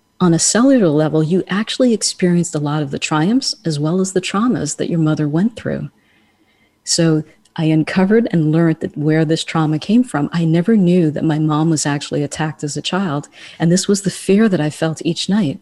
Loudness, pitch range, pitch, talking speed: -16 LUFS, 155-190 Hz, 165 Hz, 210 wpm